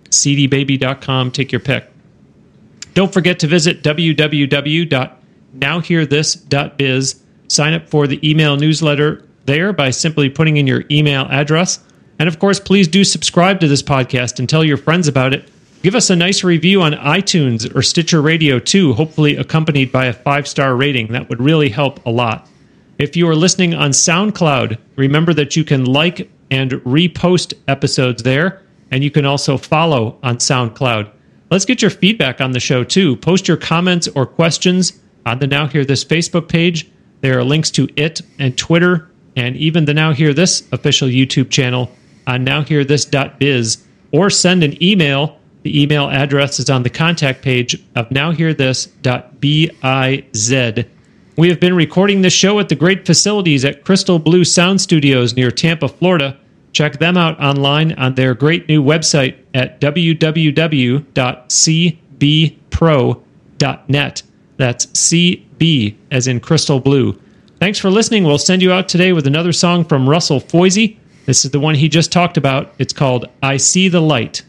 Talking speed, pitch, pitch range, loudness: 160 wpm, 150 Hz, 135-170 Hz, -13 LUFS